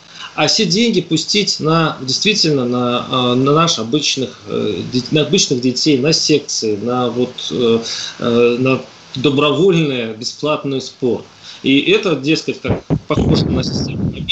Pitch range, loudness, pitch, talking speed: 125-160 Hz, -15 LUFS, 140 Hz, 115 wpm